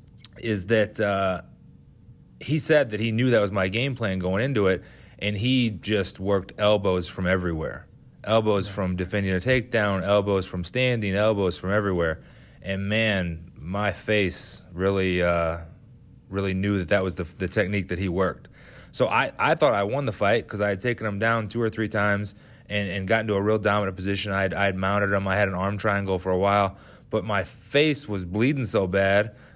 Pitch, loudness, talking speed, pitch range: 100 Hz, -24 LUFS, 195 wpm, 95-110 Hz